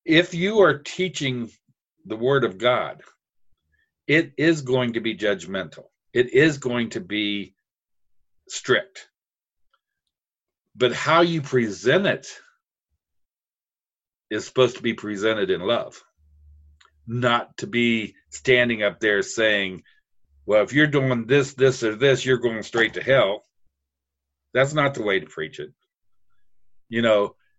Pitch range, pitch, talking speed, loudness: 100-135 Hz, 115 Hz, 135 wpm, -22 LUFS